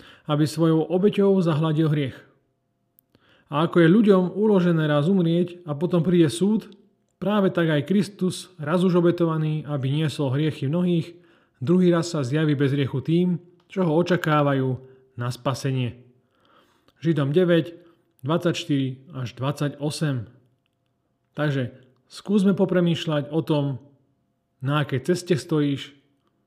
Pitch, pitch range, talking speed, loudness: 155 Hz, 140-175 Hz, 120 wpm, -23 LUFS